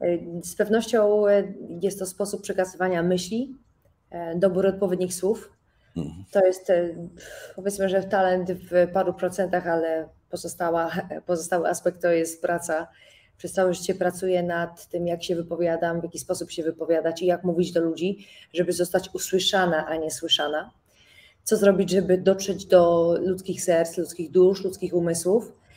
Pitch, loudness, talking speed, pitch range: 180 Hz, -24 LUFS, 140 wpm, 170-190 Hz